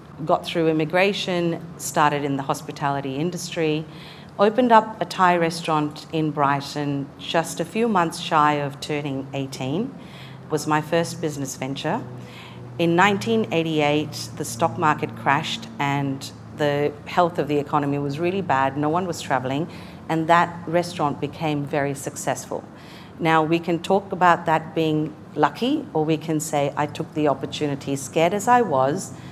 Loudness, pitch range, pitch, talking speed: -22 LUFS, 145-170 Hz, 155 Hz, 150 wpm